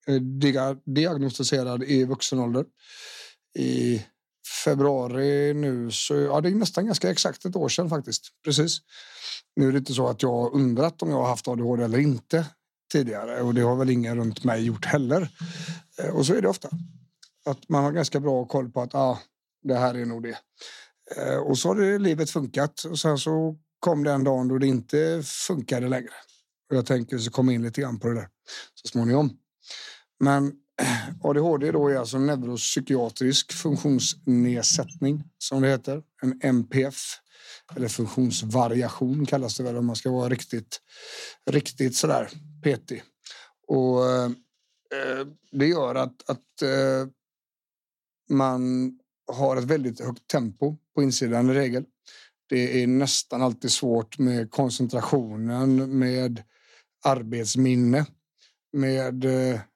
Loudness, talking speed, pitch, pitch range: -25 LUFS, 150 wpm, 135 Hz, 125-145 Hz